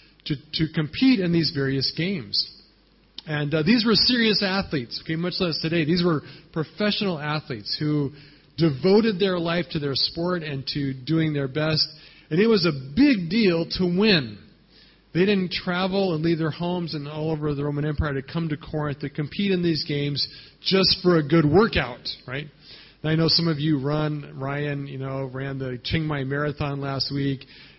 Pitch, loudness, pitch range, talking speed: 155 Hz, -23 LUFS, 145-175 Hz, 185 wpm